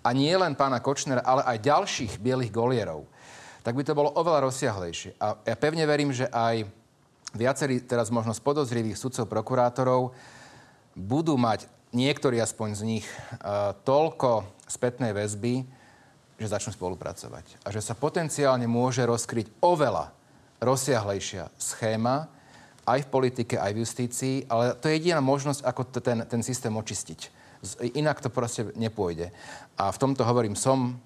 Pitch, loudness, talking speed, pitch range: 125 Hz, -27 LUFS, 145 wpm, 115-135 Hz